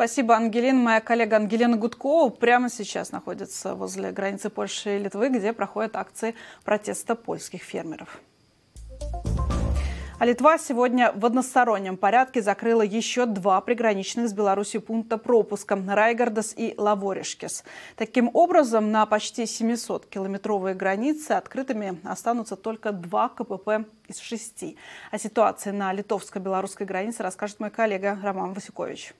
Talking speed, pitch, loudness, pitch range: 125 wpm, 220 Hz, -25 LUFS, 200-235 Hz